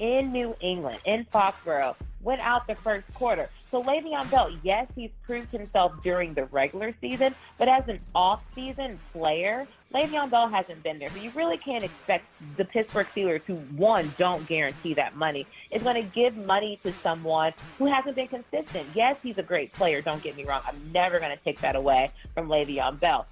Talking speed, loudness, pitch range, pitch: 195 wpm, -27 LUFS, 160-245 Hz, 200 Hz